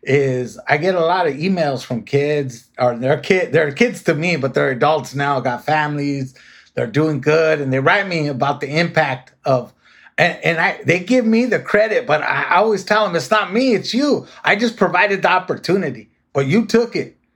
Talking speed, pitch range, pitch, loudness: 210 wpm, 140-200 Hz, 155 Hz, -17 LUFS